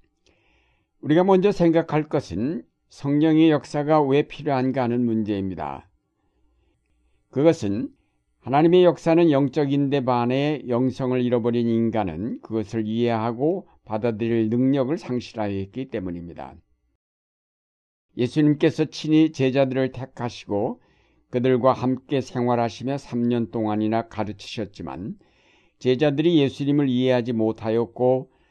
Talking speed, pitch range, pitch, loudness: 275 characters per minute, 110-145 Hz, 125 Hz, -22 LUFS